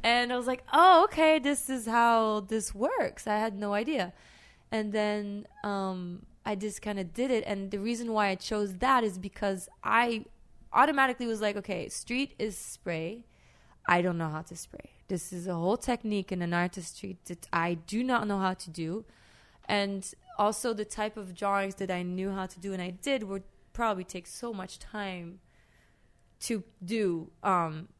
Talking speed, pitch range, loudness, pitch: 190 wpm, 185-225 Hz, -30 LUFS, 205 Hz